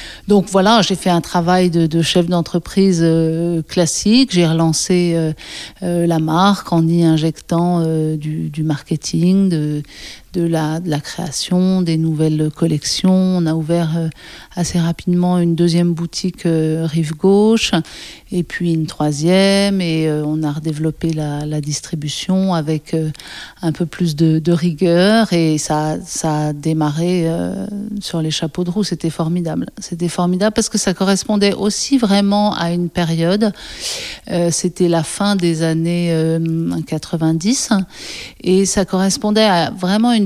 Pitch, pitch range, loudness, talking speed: 170 Hz, 160-185 Hz, -16 LUFS, 150 wpm